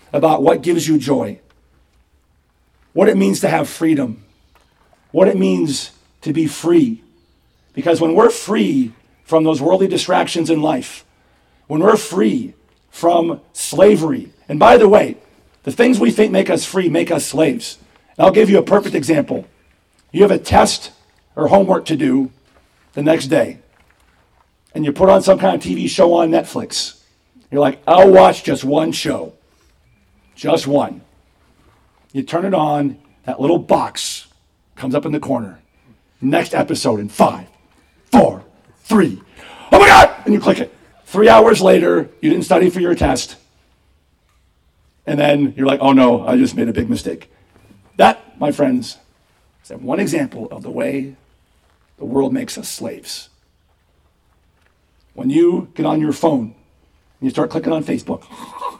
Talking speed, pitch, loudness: 160 wpm, 135 Hz, -14 LUFS